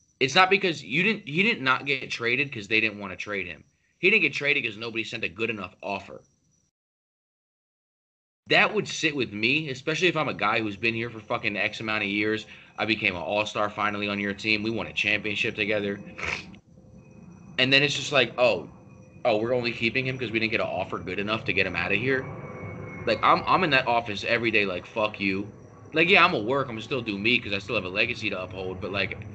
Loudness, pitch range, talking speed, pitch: -25 LUFS, 105-130 Hz, 240 wpm, 110 Hz